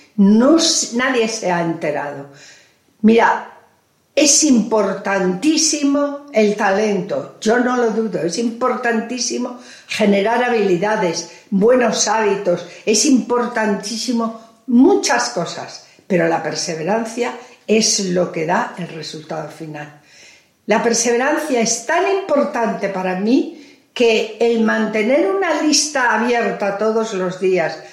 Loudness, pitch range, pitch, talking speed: -16 LUFS, 185-245 Hz, 225 Hz, 105 wpm